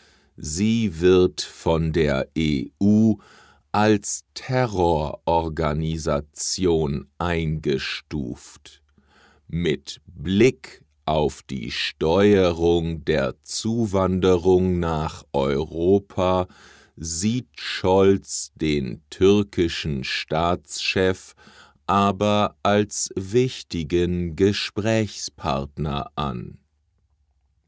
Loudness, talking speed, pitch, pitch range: -22 LUFS, 60 wpm, 85 Hz, 75-100 Hz